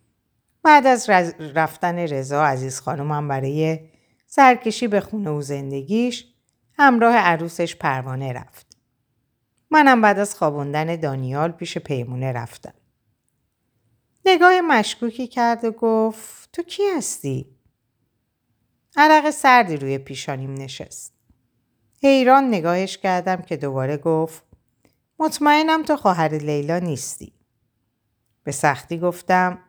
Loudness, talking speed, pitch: -19 LUFS, 105 wpm, 165 Hz